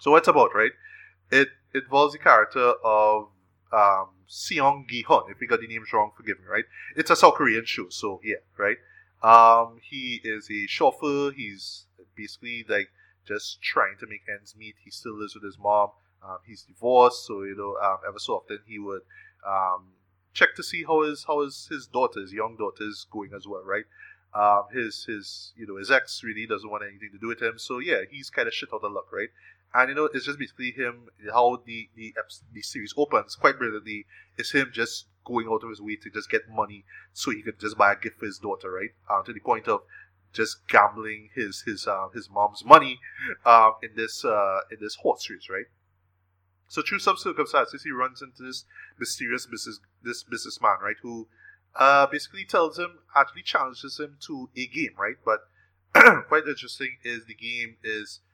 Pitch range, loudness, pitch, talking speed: 100-130 Hz, -24 LUFS, 110 Hz, 200 wpm